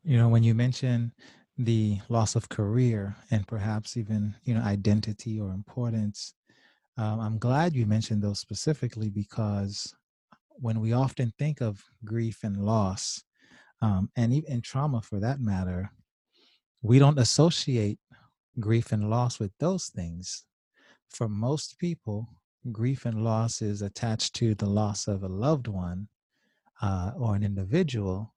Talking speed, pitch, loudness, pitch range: 145 wpm, 110 Hz, -28 LUFS, 105-120 Hz